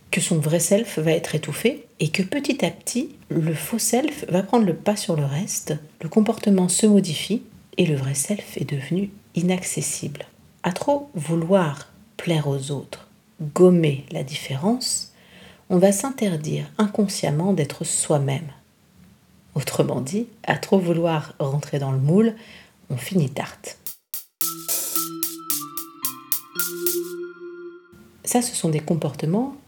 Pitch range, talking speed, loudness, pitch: 155-215 Hz, 130 wpm, -23 LUFS, 175 Hz